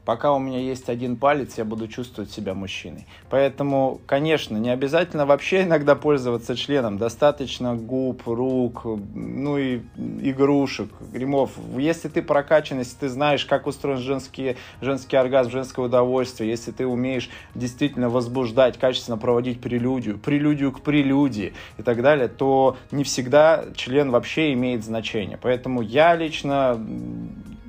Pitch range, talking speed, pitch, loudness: 120-140 Hz, 135 wpm, 130 Hz, -22 LUFS